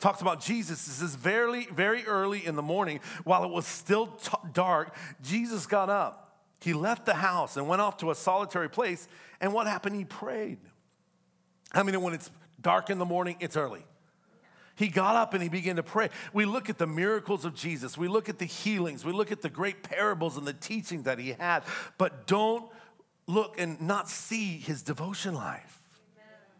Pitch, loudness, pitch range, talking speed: 185 Hz, -30 LUFS, 170-205 Hz, 195 wpm